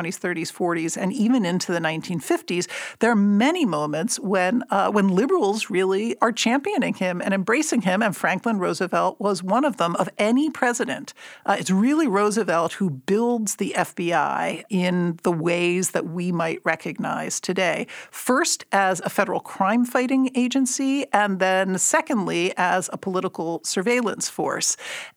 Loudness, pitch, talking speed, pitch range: -22 LUFS, 200 Hz, 155 wpm, 180-240 Hz